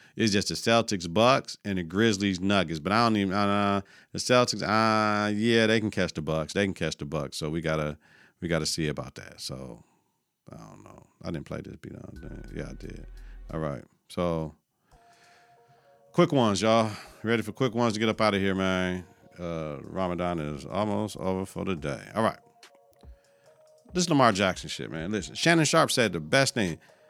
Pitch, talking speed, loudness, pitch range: 100 Hz, 200 wpm, -27 LUFS, 85-115 Hz